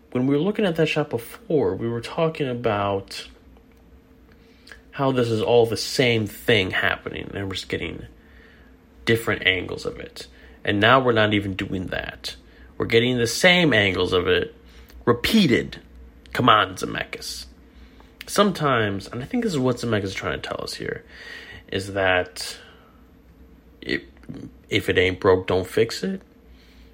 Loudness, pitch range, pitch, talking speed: -22 LUFS, 95-130 Hz, 110 Hz, 155 wpm